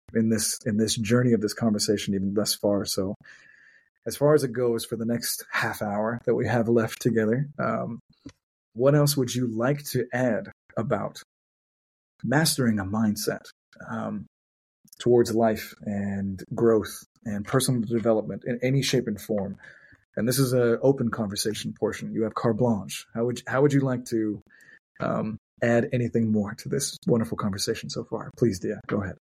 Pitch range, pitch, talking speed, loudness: 105-125 Hz, 115 Hz, 175 wpm, -26 LUFS